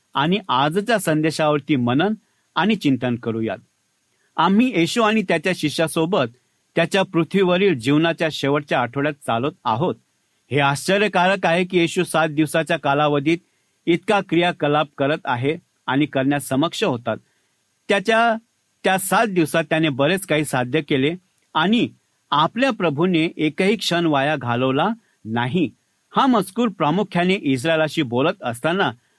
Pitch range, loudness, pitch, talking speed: 145-190 Hz, -20 LUFS, 165 Hz, 120 wpm